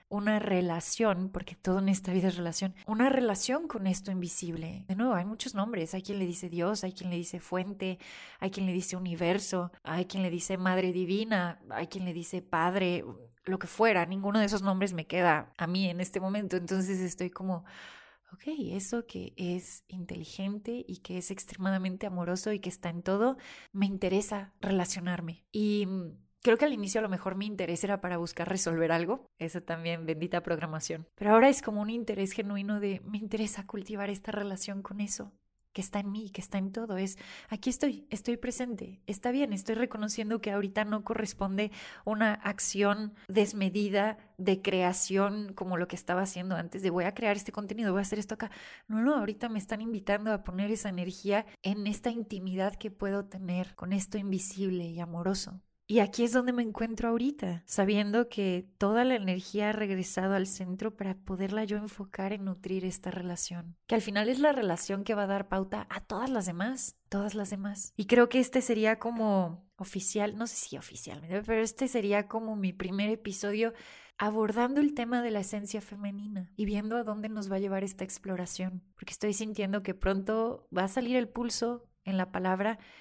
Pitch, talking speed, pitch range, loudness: 200 Hz, 195 wpm, 185-215 Hz, -32 LUFS